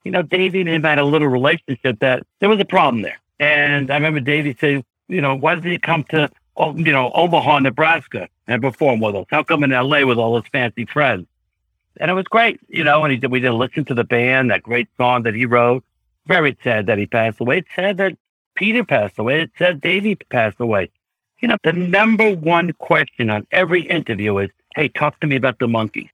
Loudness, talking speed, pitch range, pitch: -17 LUFS, 225 wpm, 125-170 Hz, 145 Hz